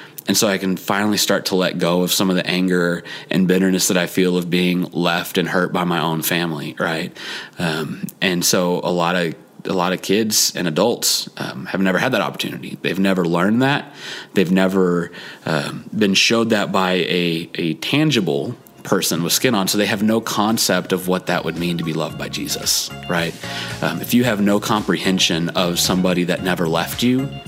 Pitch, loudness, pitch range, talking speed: 90 Hz, -18 LUFS, 85-100 Hz, 205 wpm